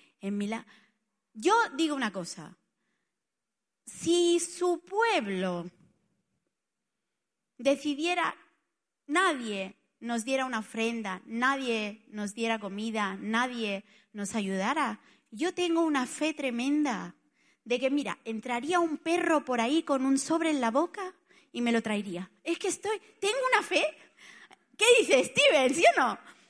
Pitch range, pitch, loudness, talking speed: 220-335 Hz, 265 Hz, -29 LUFS, 130 wpm